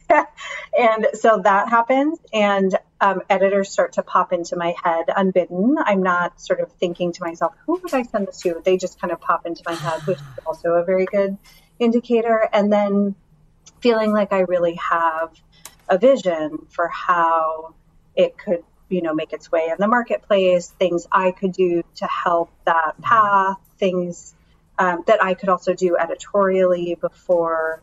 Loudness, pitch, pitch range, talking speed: -20 LUFS, 185 Hz, 170-200 Hz, 175 wpm